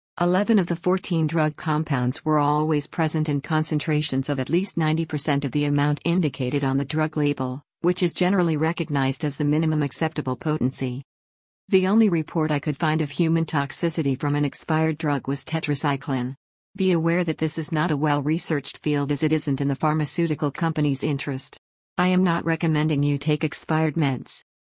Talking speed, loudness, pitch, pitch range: 180 wpm, -23 LUFS, 155 Hz, 145-165 Hz